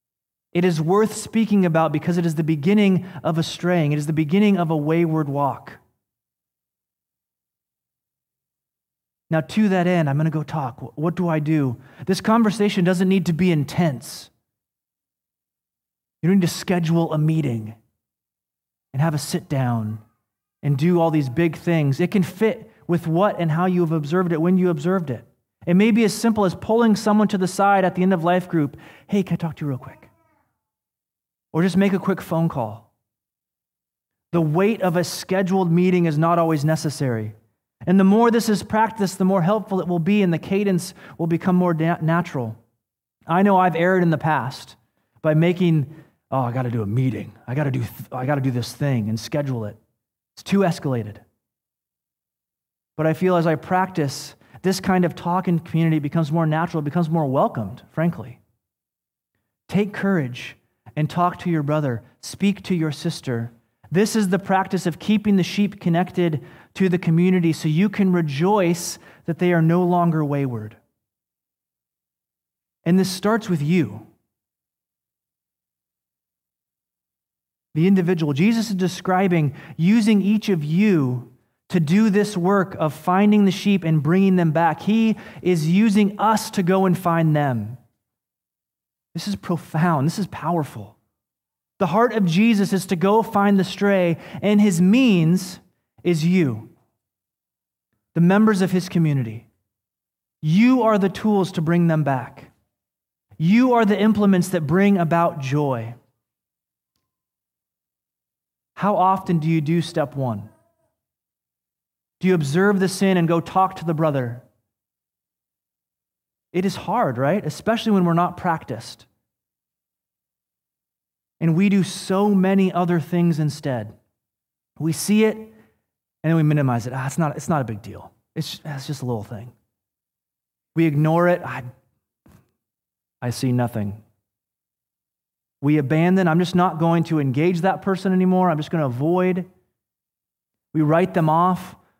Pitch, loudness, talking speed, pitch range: 165 Hz, -20 LUFS, 160 wpm, 130-185 Hz